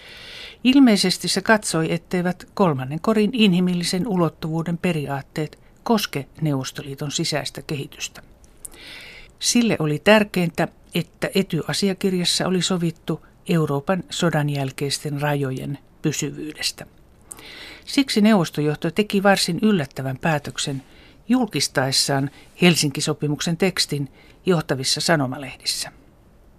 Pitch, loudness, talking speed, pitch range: 165 Hz, -21 LUFS, 80 wpm, 145-190 Hz